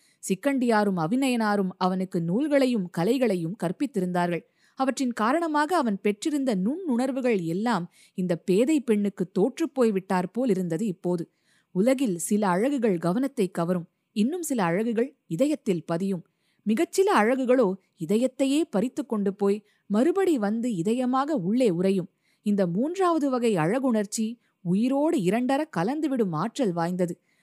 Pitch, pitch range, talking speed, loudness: 220 Hz, 185-260 Hz, 110 wpm, -26 LUFS